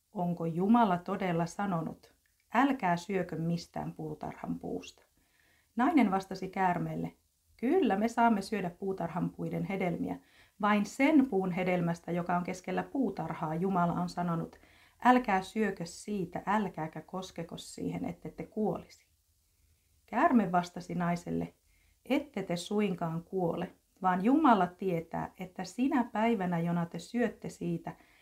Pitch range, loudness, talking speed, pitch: 170-210 Hz, -32 LUFS, 120 wpm, 180 Hz